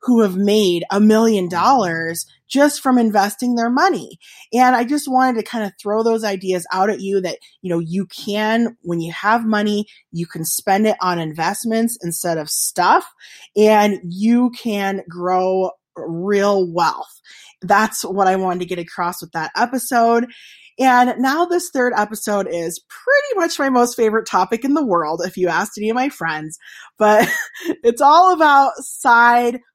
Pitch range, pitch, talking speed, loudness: 185-245 Hz, 210 Hz, 170 wpm, -17 LUFS